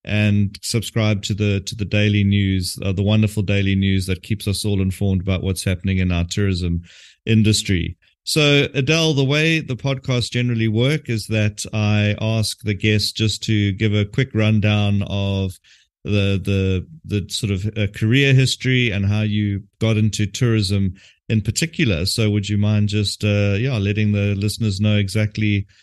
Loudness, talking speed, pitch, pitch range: -19 LUFS, 170 wpm, 105 Hz, 100-110 Hz